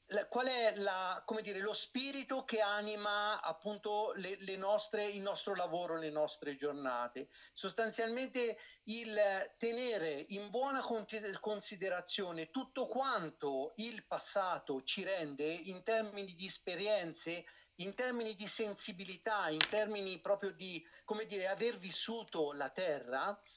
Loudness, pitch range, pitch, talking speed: -39 LUFS, 185-220 Hz, 205 Hz, 125 wpm